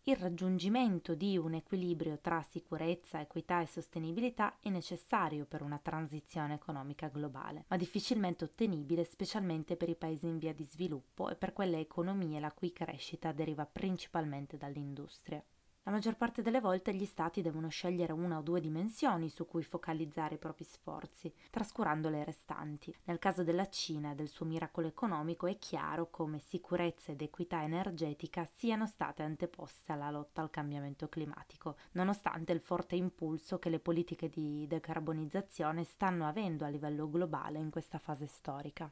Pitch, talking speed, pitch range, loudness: 165 Hz, 155 wpm, 155-180 Hz, -39 LUFS